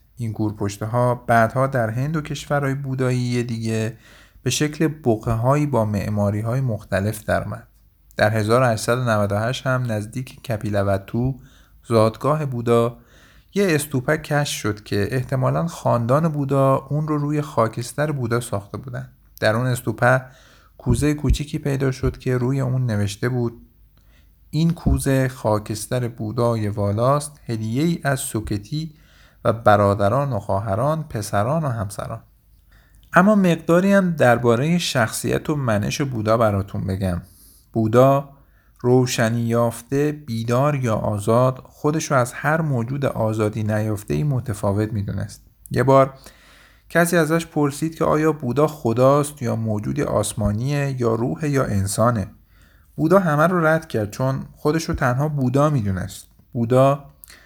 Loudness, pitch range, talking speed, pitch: -21 LUFS, 110-140 Hz, 125 wpm, 120 Hz